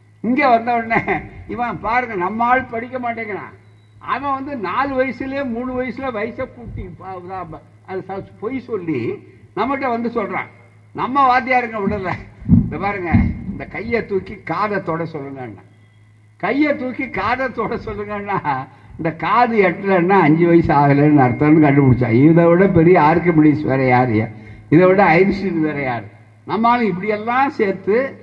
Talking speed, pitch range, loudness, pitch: 130 wpm, 140-235 Hz, -17 LUFS, 190 Hz